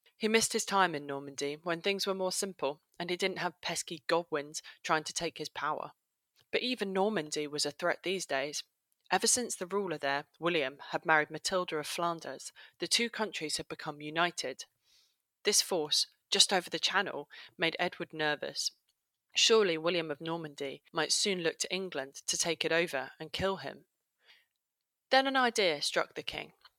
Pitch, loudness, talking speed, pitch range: 170 Hz, -32 LUFS, 175 wpm, 155-190 Hz